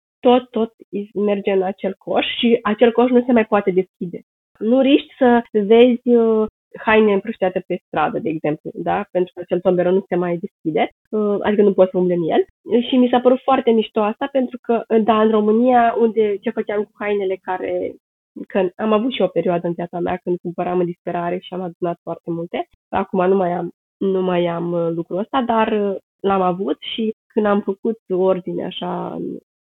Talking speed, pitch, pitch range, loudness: 190 wpm, 205 Hz, 180-230 Hz, -19 LUFS